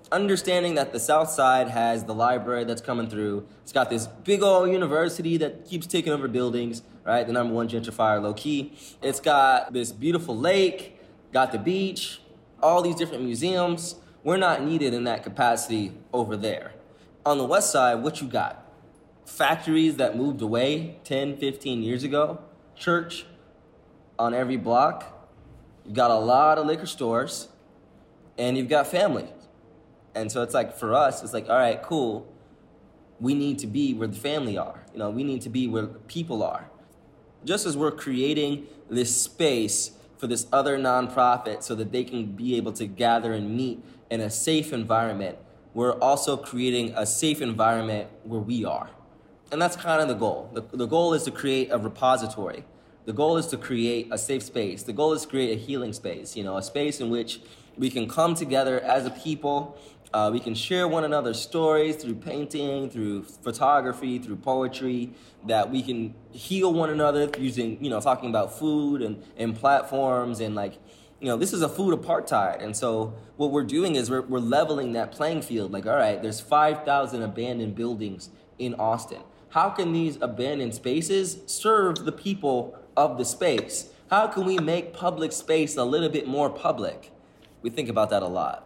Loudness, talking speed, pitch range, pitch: -25 LUFS, 185 wpm, 115-155 Hz, 130 Hz